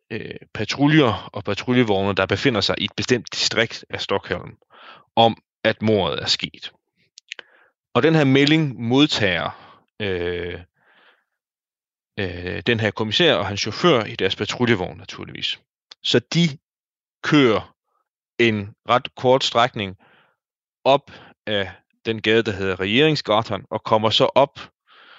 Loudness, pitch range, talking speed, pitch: -20 LUFS, 100-125 Hz, 125 wpm, 110 Hz